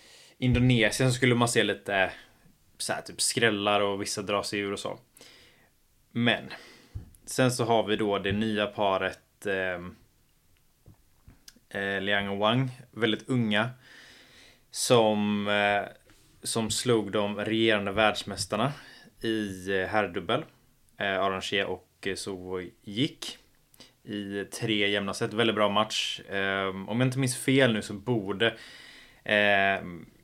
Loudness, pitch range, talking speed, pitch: -27 LUFS, 100-115 Hz, 125 wpm, 105 Hz